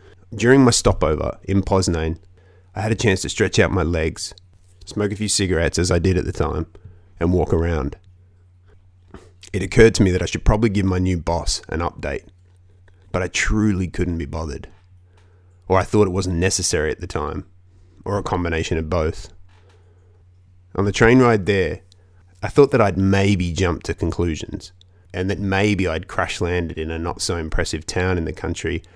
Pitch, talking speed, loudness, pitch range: 90 Hz, 185 wpm, -20 LUFS, 85-100 Hz